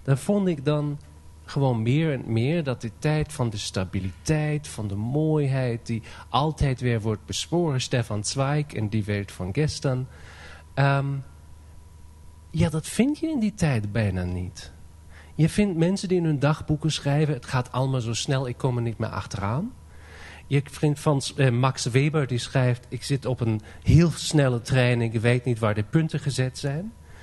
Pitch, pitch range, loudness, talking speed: 130 Hz, 105-150 Hz, -25 LUFS, 180 wpm